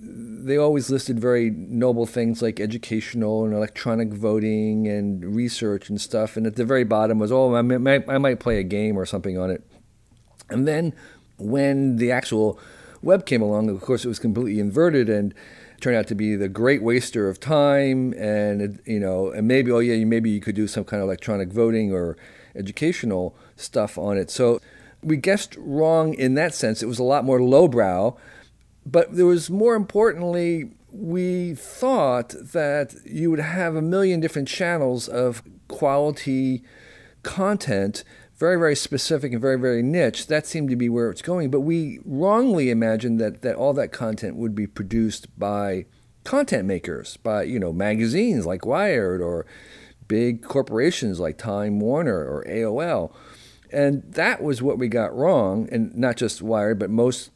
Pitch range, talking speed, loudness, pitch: 110-145 Hz, 170 wpm, -22 LUFS, 120 Hz